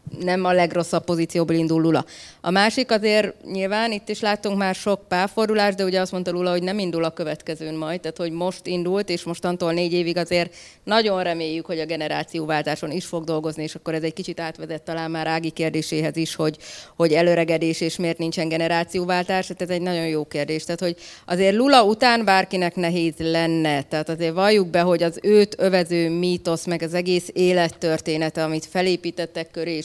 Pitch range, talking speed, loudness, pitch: 165-185 Hz, 185 wpm, -22 LUFS, 170 Hz